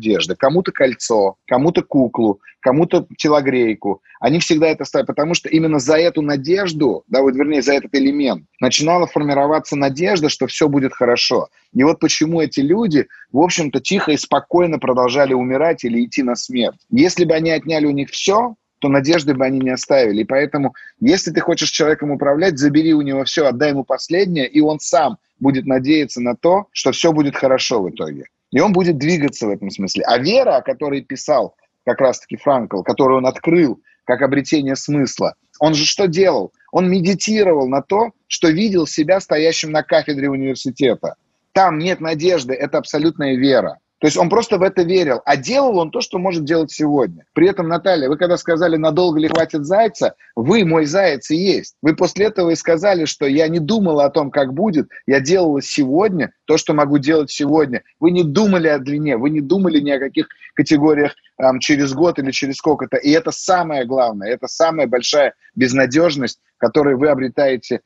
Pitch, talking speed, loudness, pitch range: 155 Hz, 185 wpm, -16 LUFS, 140-175 Hz